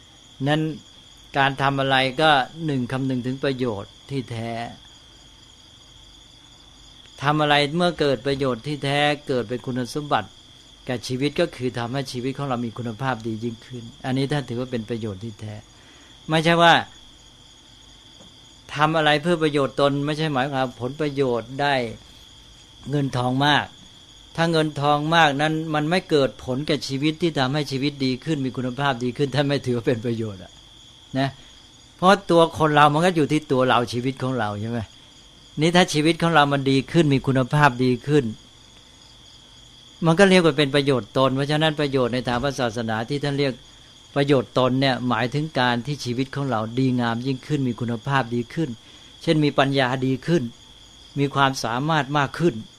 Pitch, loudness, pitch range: 135 Hz, -22 LUFS, 125-150 Hz